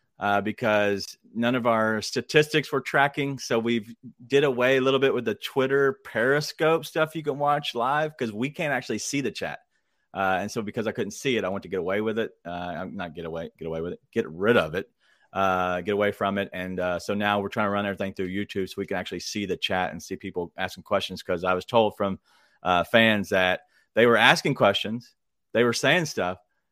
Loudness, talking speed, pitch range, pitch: -25 LUFS, 235 wpm, 100-135 Hz, 110 Hz